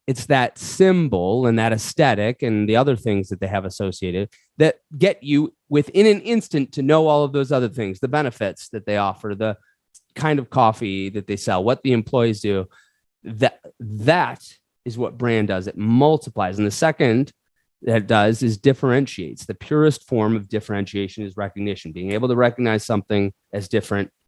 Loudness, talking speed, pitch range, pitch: -20 LUFS, 180 wpm, 100-135 Hz, 115 Hz